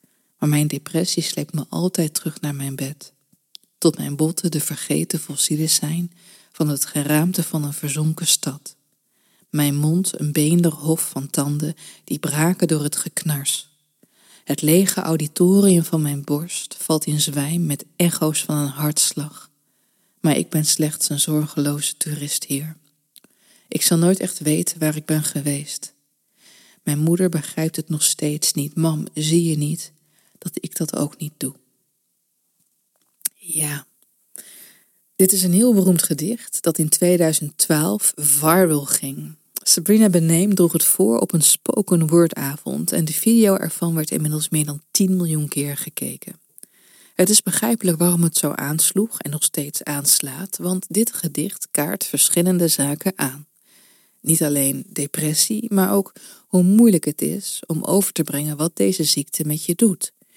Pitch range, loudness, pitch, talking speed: 150-175 Hz, -19 LUFS, 155 Hz, 155 wpm